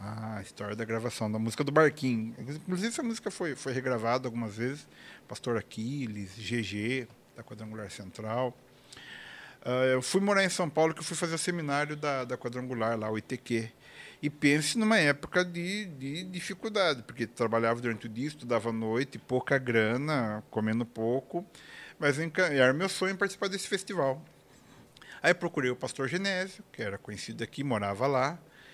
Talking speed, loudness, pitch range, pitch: 165 wpm, -31 LUFS, 115-165 Hz, 130 Hz